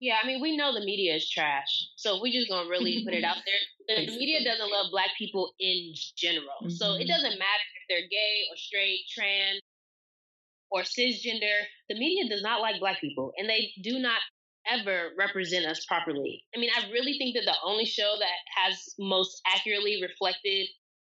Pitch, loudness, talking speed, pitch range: 200 Hz, -28 LUFS, 190 wpm, 185-230 Hz